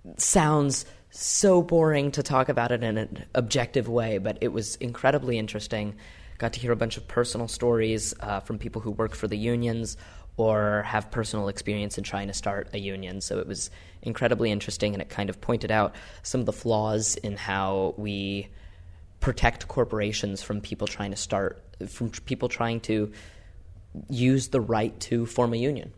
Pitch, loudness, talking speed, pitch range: 110 Hz, -27 LUFS, 180 wpm, 100-120 Hz